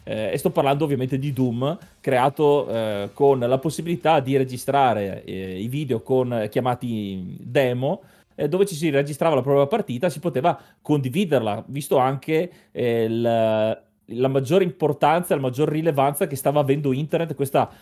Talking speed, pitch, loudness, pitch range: 160 wpm, 140 Hz, -22 LUFS, 125-160 Hz